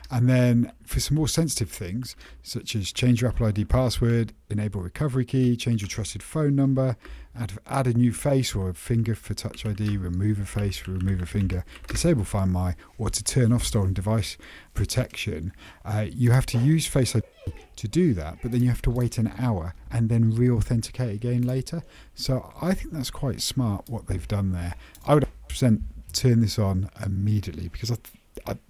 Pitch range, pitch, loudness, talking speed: 100-125 Hz, 115 Hz, -25 LUFS, 195 wpm